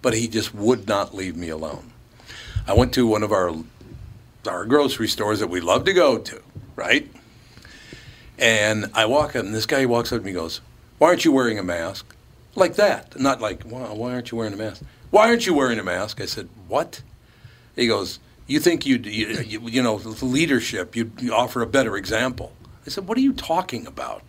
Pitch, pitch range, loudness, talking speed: 115 Hz, 110-130 Hz, -21 LUFS, 205 wpm